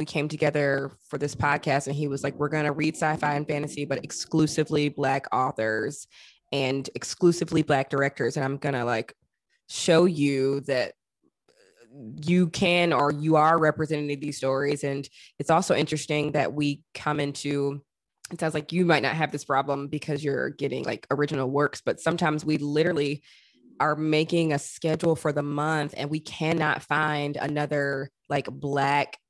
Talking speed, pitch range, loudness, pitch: 165 wpm, 140-155 Hz, -26 LUFS, 145 Hz